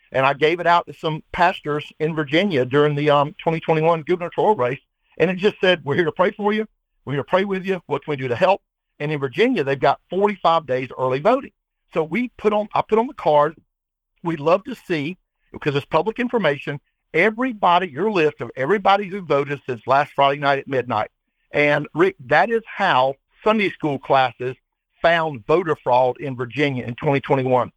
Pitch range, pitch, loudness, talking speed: 140-190 Hz, 155 Hz, -20 LUFS, 195 wpm